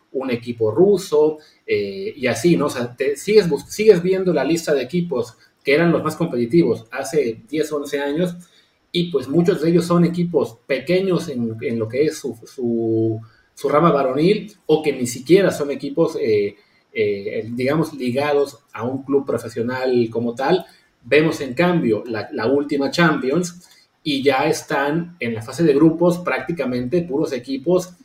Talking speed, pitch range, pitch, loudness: 170 wpm, 130-180 Hz, 155 Hz, -19 LUFS